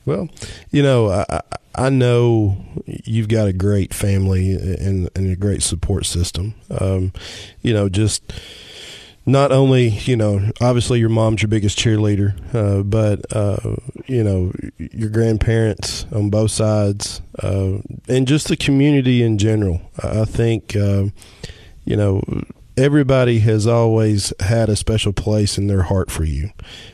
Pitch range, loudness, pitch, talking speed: 100-115 Hz, -18 LUFS, 105 Hz, 145 wpm